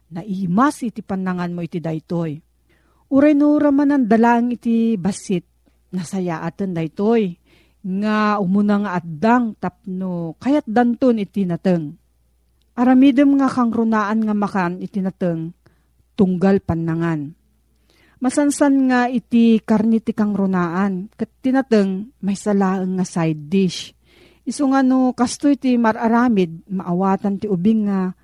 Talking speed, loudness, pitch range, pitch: 120 wpm, -18 LUFS, 185-240 Hz, 205 Hz